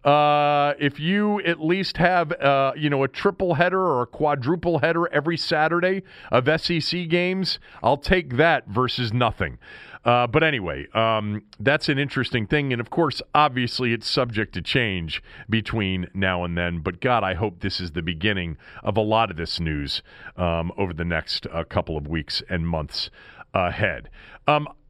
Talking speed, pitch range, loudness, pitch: 175 wpm, 95-155 Hz, -23 LUFS, 125 Hz